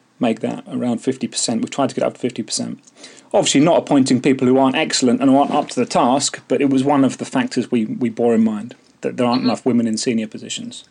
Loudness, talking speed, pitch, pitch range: -18 LUFS, 250 wpm, 125 Hz, 120-135 Hz